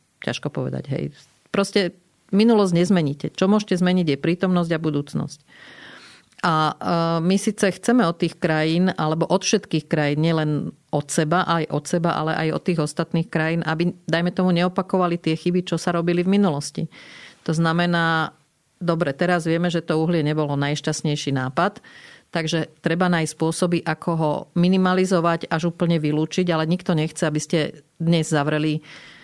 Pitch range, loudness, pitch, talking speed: 155-180 Hz, -22 LUFS, 170 Hz, 155 wpm